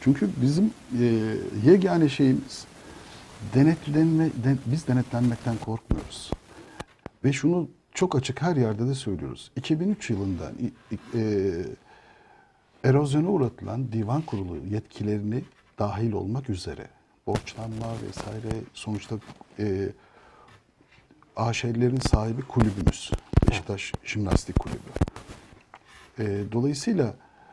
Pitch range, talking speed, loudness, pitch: 105-135 Hz, 90 wpm, -26 LUFS, 115 Hz